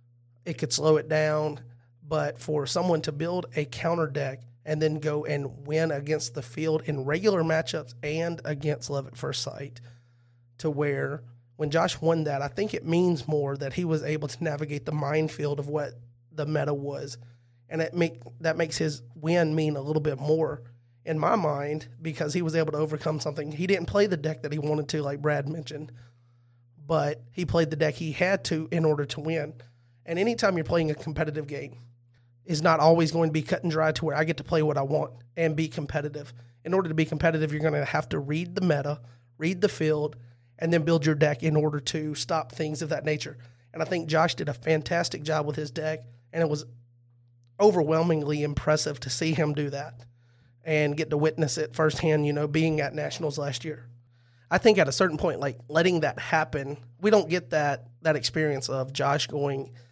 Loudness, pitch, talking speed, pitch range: -27 LUFS, 150 Hz, 210 wpm, 140-160 Hz